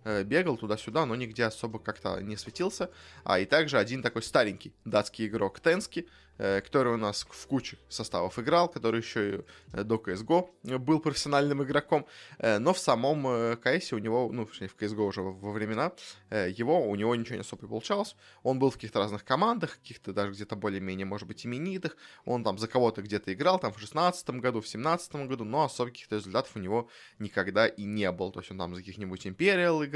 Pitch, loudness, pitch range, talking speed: 115 Hz, -30 LUFS, 105-145 Hz, 190 wpm